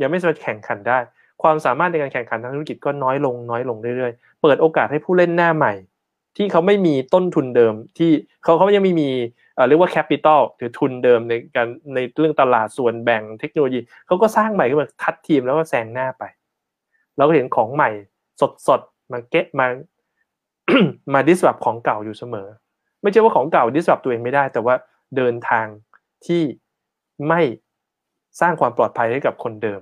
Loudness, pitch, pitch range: -18 LUFS, 140 Hz, 120-165 Hz